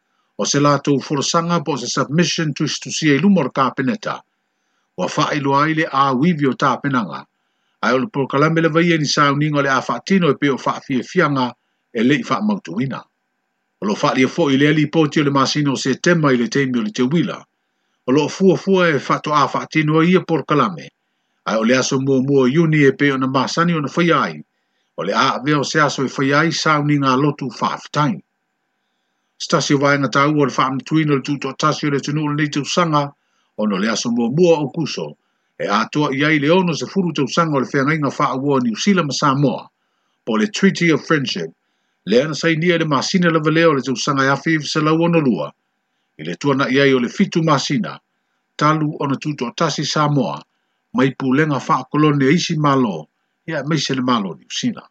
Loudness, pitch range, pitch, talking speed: -17 LUFS, 135-165 Hz, 145 Hz, 190 wpm